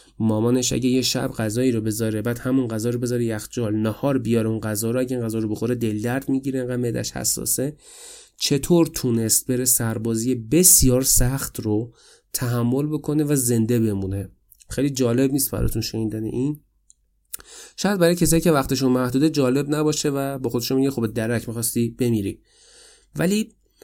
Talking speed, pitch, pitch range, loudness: 160 wpm, 125 Hz, 115-140 Hz, -21 LUFS